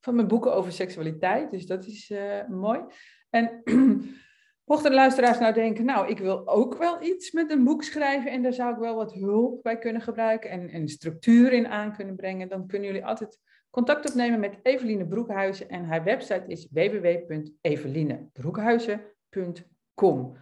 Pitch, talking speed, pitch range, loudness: 220 Hz, 170 wpm, 190-245 Hz, -26 LUFS